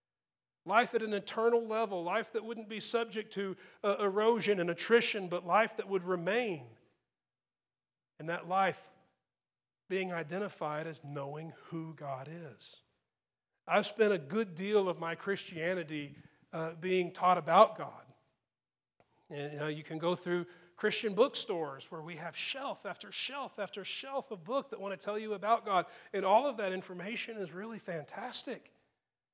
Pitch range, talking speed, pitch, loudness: 170-220 Hz, 155 wpm, 195 Hz, -34 LUFS